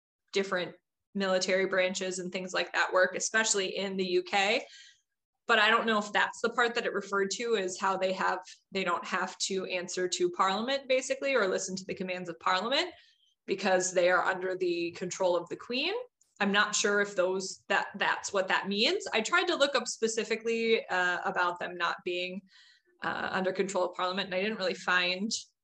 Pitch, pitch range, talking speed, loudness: 195 Hz, 185-225 Hz, 195 wpm, -30 LUFS